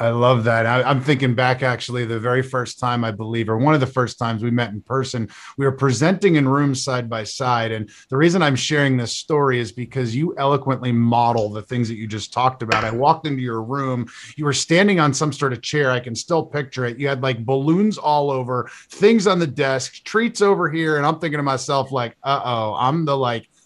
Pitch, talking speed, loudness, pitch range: 130 Hz, 235 wpm, -20 LUFS, 120-145 Hz